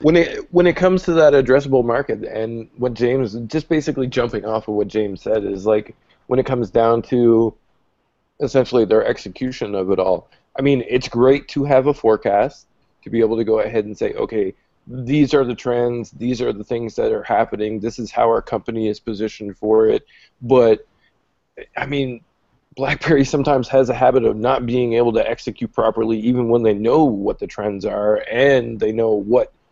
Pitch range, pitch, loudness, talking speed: 115-135 Hz, 120 Hz, -18 LUFS, 195 wpm